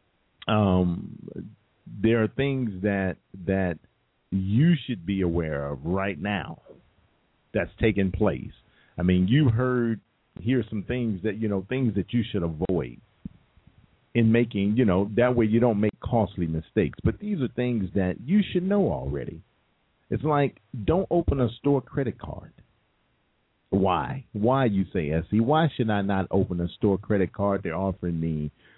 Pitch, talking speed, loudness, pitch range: 105 Hz, 160 wpm, -26 LUFS, 95-125 Hz